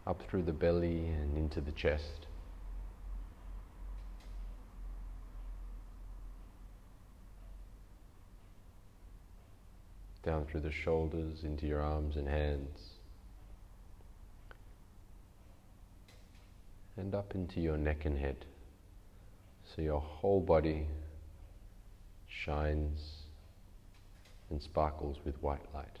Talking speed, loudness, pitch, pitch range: 80 wpm, -38 LUFS, 90 Hz, 75-95 Hz